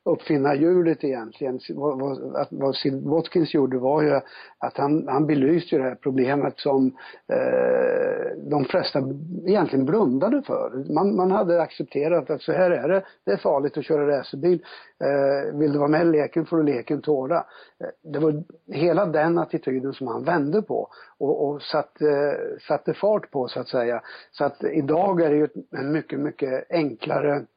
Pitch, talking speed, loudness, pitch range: 150 Hz, 170 wpm, -23 LUFS, 140-175 Hz